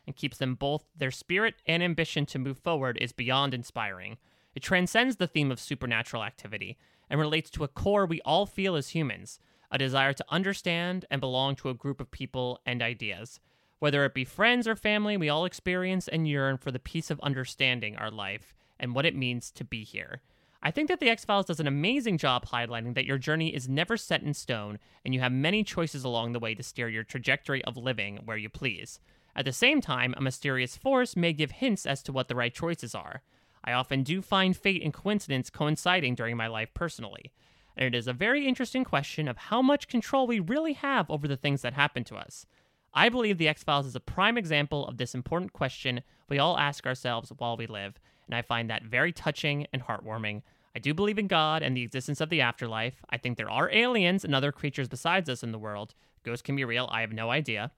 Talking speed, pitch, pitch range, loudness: 225 wpm, 140 Hz, 120-170 Hz, -29 LUFS